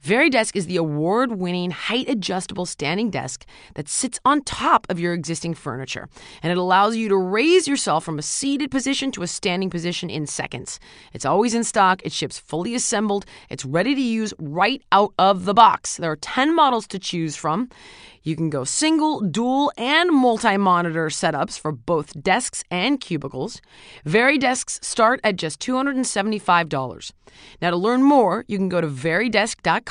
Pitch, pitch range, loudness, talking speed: 195 Hz, 170-245 Hz, -21 LUFS, 170 wpm